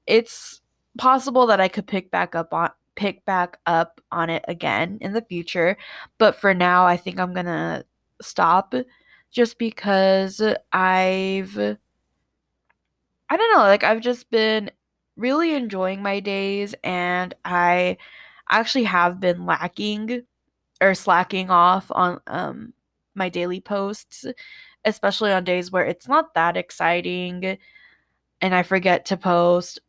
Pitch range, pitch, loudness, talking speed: 180-220 Hz, 190 Hz, -21 LUFS, 135 wpm